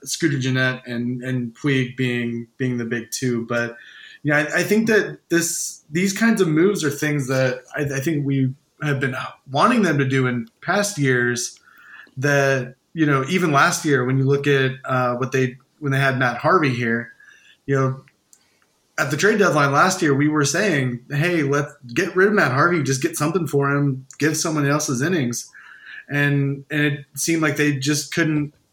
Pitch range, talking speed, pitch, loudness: 130-155 Hz, 190 wpm, 140 Hz, -20 LUFS